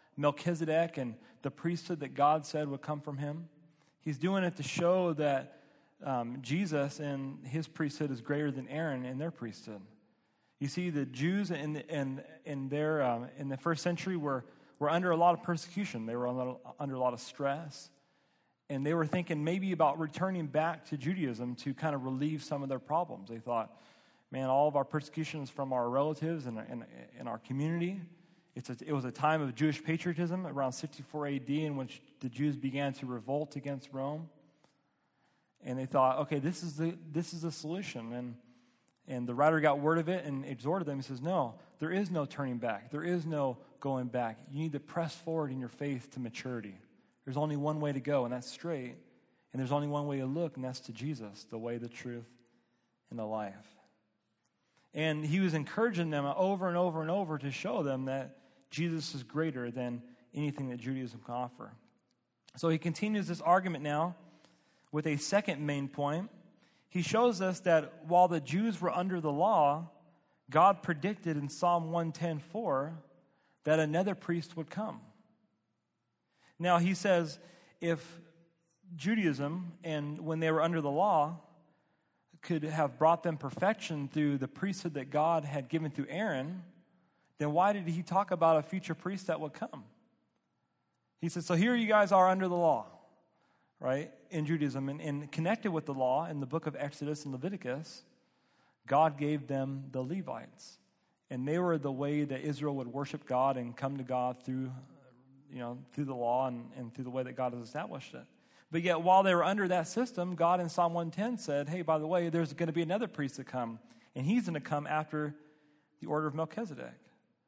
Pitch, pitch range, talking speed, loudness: 150 Hz, 135-170 Hz, 190 wpm, -34 LUFS